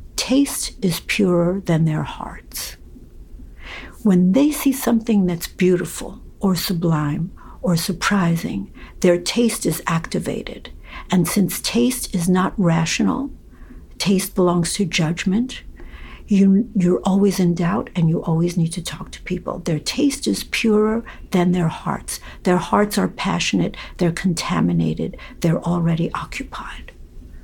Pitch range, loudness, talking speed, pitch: 165-200 Hz, -20 LUFS, 130 wpm, 180 Hz